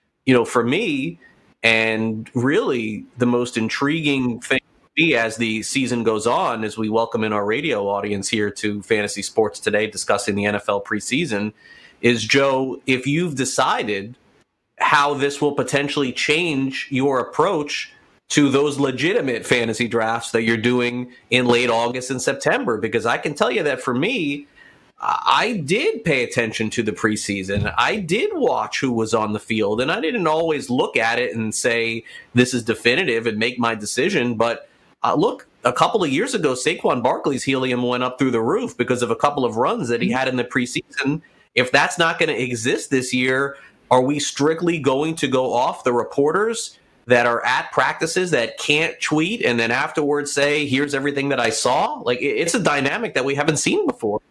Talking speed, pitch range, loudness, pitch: 185 wpm, 115-140 Hz, -20 LUFS, 125 Hz